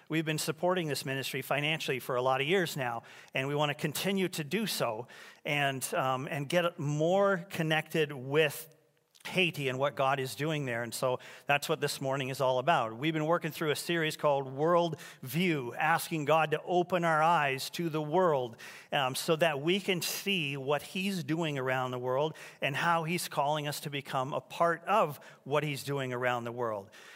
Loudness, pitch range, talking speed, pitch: -31 LUFS, 135-170 Hz, 195 wpm, 155 Hz